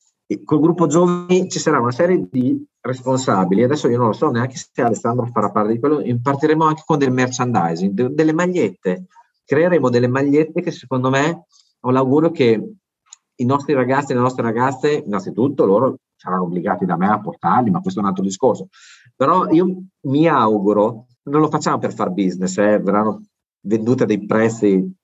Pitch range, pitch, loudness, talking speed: 115-165 Hz, 135 Hz, -18 LUFS, 180 wpm